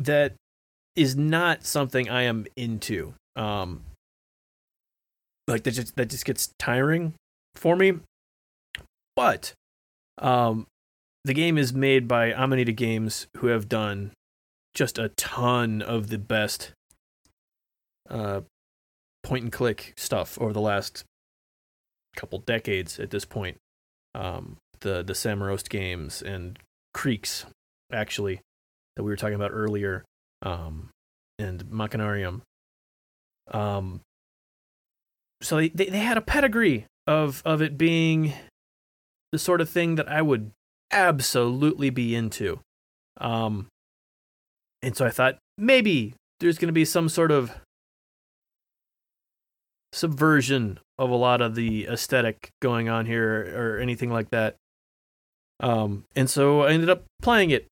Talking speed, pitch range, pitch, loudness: 130 wpm, 95-135 Hz, 115 Hz, -25 LUFS